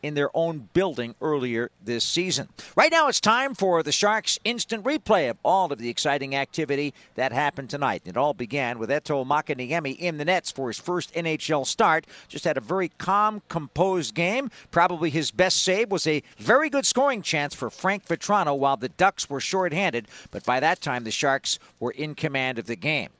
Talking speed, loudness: 195 wpm, -24 LUFS